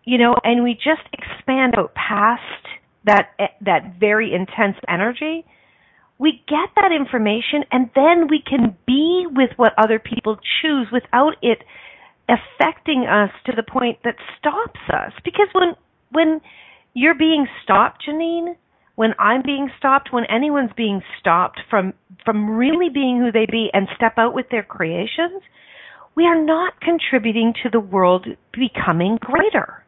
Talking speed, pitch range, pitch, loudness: 150 wpm, 225-310 Hz, 250 Hz, -18 LUFS